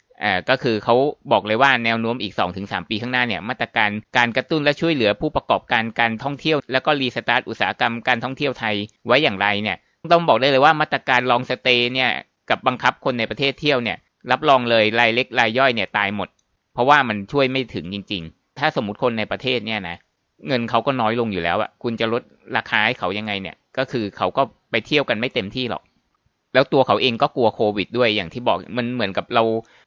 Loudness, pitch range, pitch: -20 LUFS, 105-130 Hz, 120 Hz